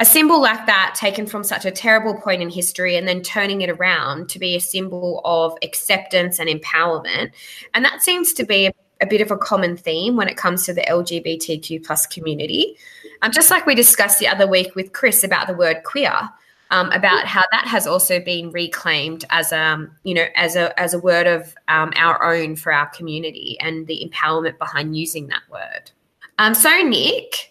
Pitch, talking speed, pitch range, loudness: 180 Hz, 205 wpm, 165-210 Hz, -17 LUFS